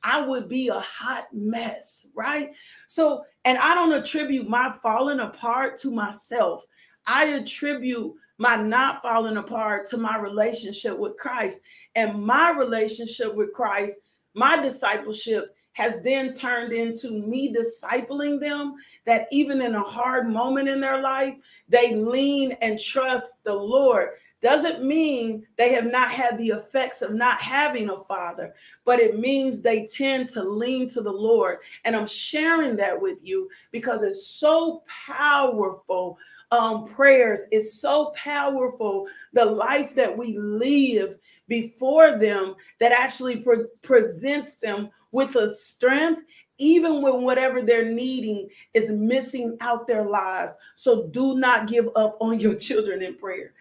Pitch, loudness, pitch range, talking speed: 250 Hz, -23 LUFS, 225-280 Hz, 145 wpm